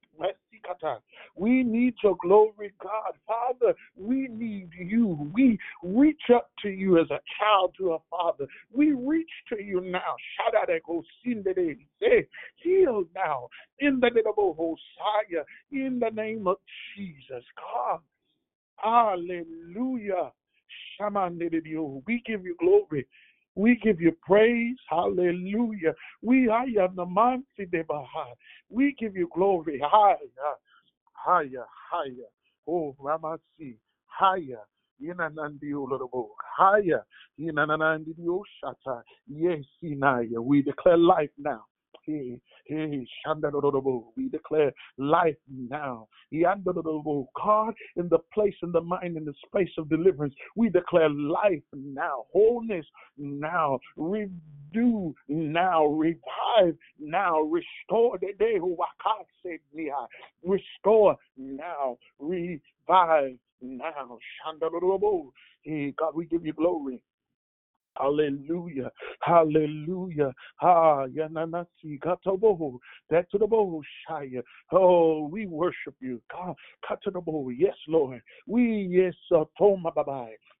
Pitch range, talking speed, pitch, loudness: 150-215 Hz, 110 wpm, 175 Hz, -26 LUFS